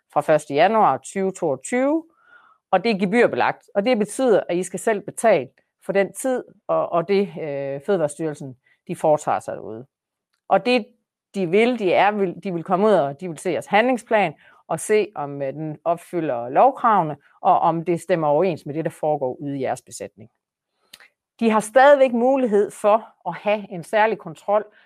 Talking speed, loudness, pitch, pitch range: 180 wpm, -21 LUFS, 190 Hz, 165-220 Hz